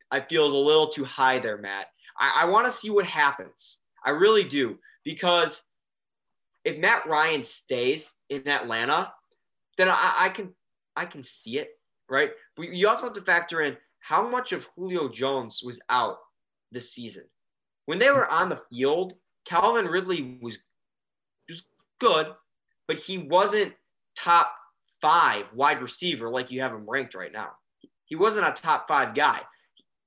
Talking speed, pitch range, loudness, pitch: 160 wpm, 130-200 Hz, -25 LUFS, 165 Hz